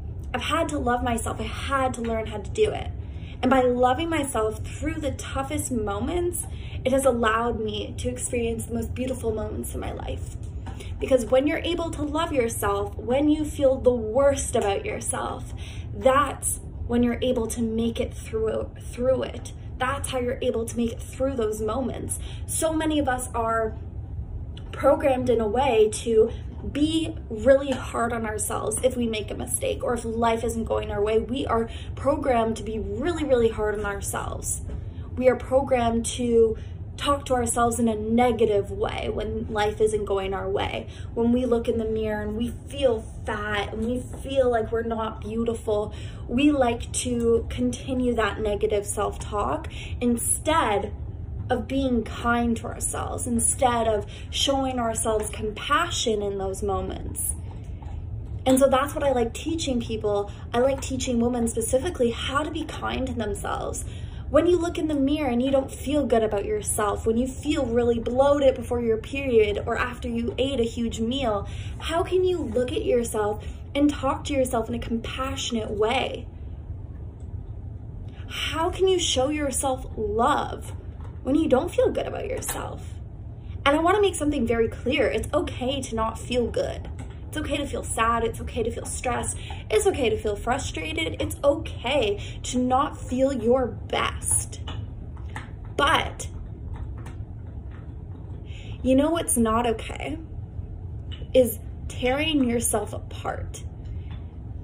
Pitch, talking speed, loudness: 235 Hz, 160 wpm, -25 LUFS